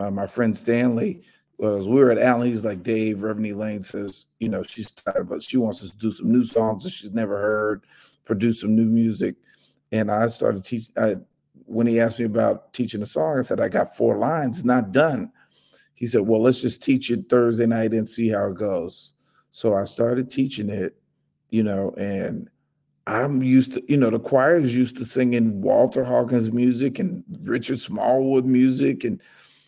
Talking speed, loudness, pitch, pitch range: 195 wpm, -22 LUFS, 115 Hz, 105-125 Hz